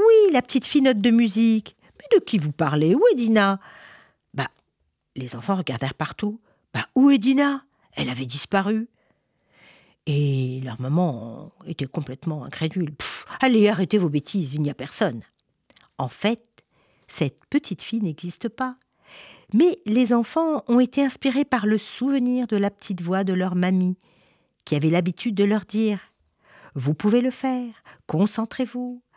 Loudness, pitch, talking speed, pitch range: -23 LUFS, 205 Hz, 155 wpm, 160-245 Hz